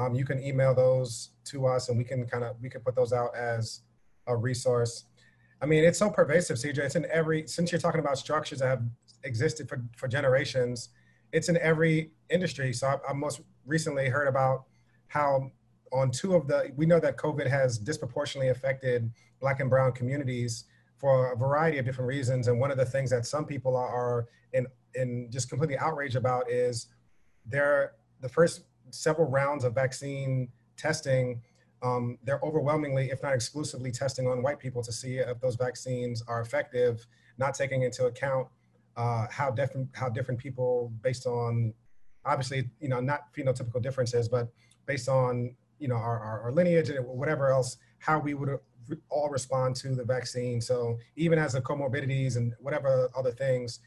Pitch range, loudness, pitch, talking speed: 125-145 Hz, -29 LUFS, 130 Hz, 180 wpm